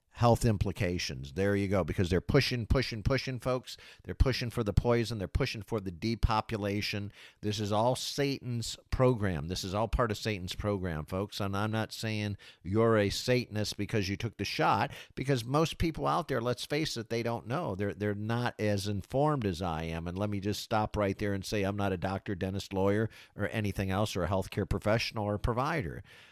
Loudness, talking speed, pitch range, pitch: -32 LUFS, 205 wpm, 100-120 Hz, 105 Hz